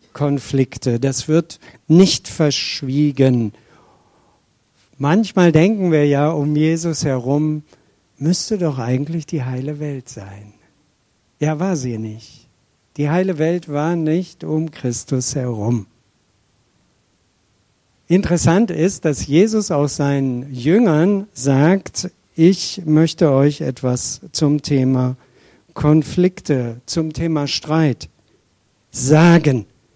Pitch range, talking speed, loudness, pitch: 125-165 Hz, 100 wpm, -17 LUFS, 145 Hz